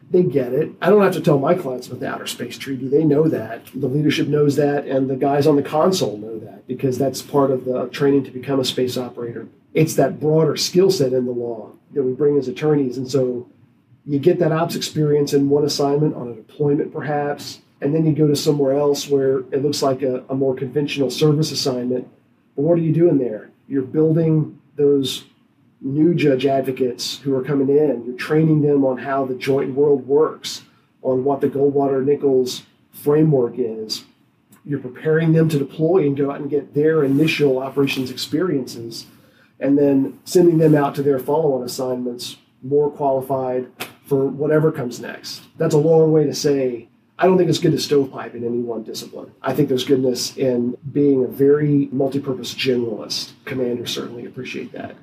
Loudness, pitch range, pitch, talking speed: -19 LUFS, 130-150 Hz, 140 Hz, 190 wpm